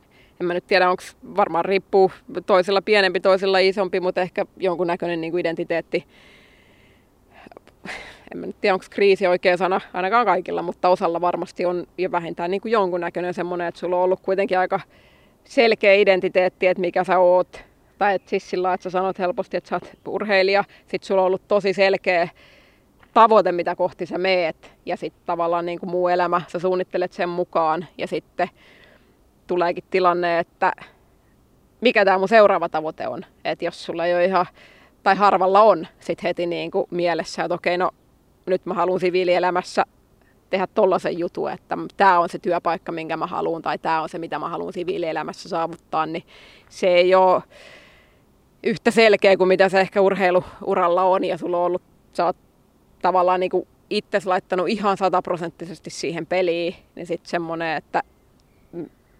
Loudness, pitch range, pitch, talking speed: -21 LUFS, 175-190 Hz, 180 Hz, 165 wpm